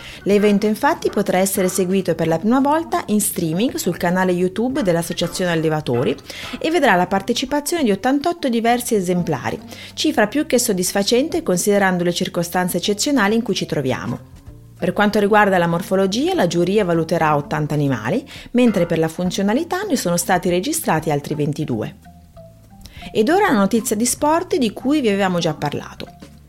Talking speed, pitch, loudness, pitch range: 155 wpm, 185 Hz, -18 LUFS, 165-235 Hz